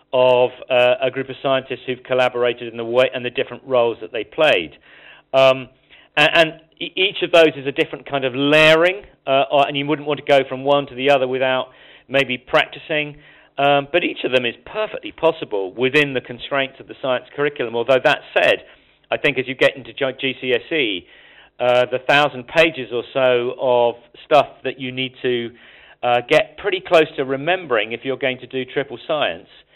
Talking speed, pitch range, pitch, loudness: 195 wpm, 125-145 Hz, 135 Hz, -18 LUFS